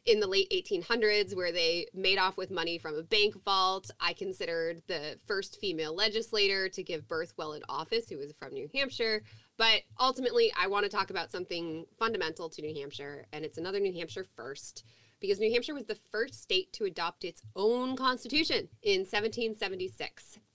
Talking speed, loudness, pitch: 185 wpm, -31 LUFS, 220 Hz